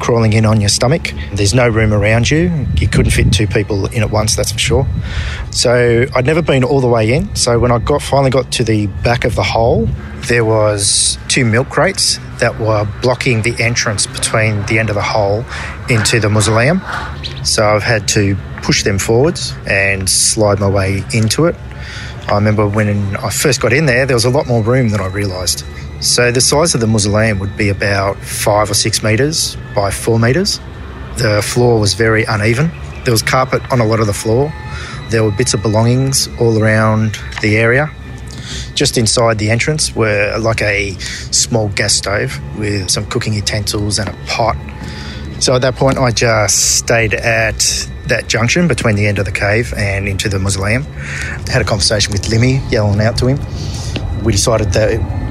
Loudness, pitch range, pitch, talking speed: -13 LUFS, 100-120 Hz, 110 Hz, 195 wpm